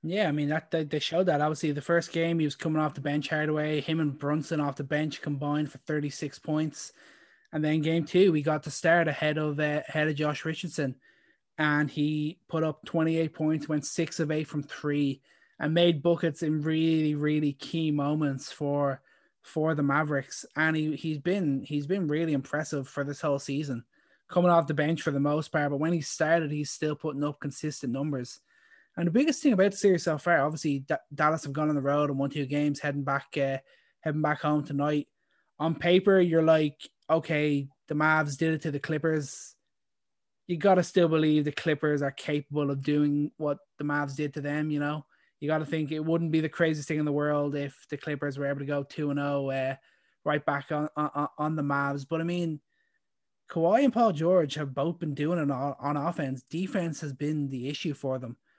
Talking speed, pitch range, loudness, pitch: 210 wpm, 145-160 Hz, -28 LUFS, 150 Hz